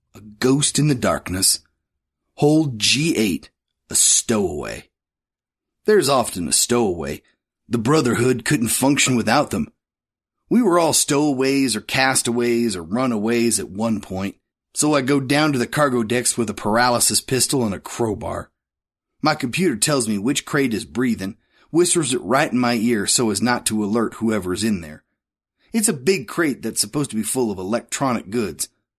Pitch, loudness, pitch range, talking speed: 120 Hz, -19 LUFS, 110-145 Hz, 165 wpm